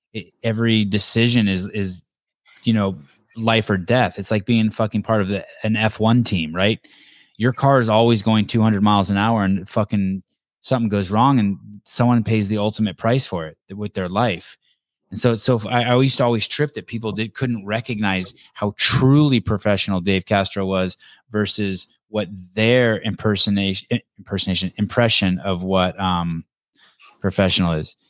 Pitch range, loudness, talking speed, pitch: 95-115 Hz, -19 LUFS, 165 wpm, 105 Hz